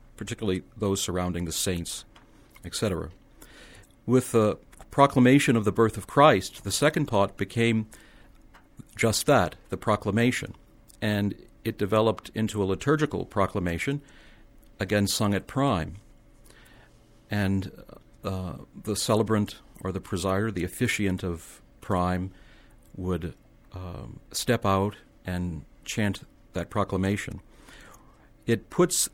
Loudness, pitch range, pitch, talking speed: -26 LUFS, 95-115 Hz, 105 Hz, 105 wpm